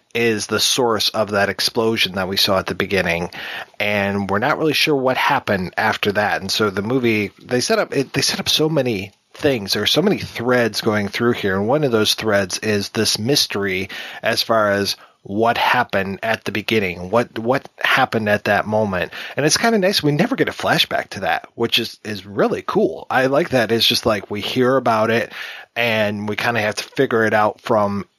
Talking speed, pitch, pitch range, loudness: 215 wpm, 110 Hz, 100-125 Hz, -18 LUFS